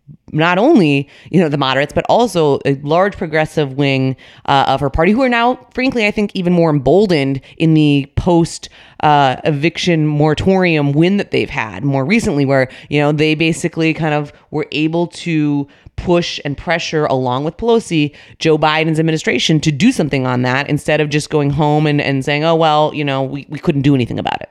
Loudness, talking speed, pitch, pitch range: -14 LUFS, 195 wpm, 155 Hz, 140-170 Hz